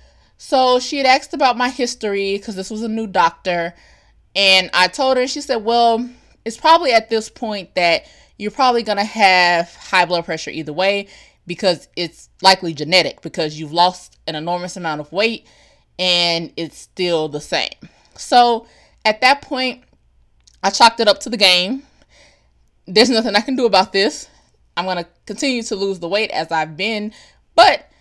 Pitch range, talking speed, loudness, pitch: 175-235 Hz, 175 wpm, -16 LUFS, 200 Hz